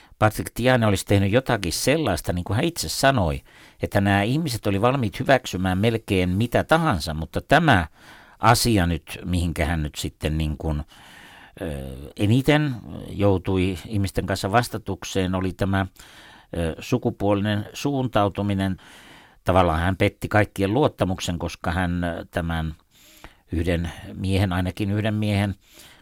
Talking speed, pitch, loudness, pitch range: 120 wpm, 100 Hz, -23 LUFS, 90-110 Hz